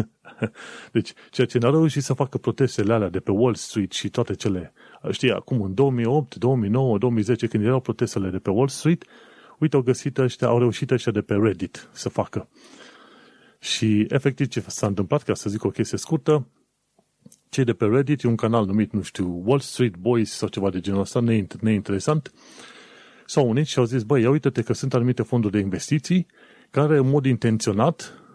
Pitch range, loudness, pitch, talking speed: 105-135 Hz, -23 LUFS, 120 Hz, 185 wpm